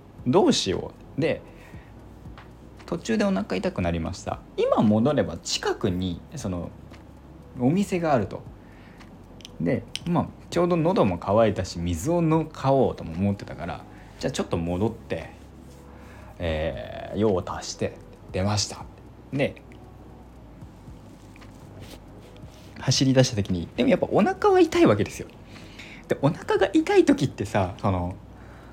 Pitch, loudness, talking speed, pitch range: 100 Hz, -25 LUFS, 245 characters per minute, 85-130 Hz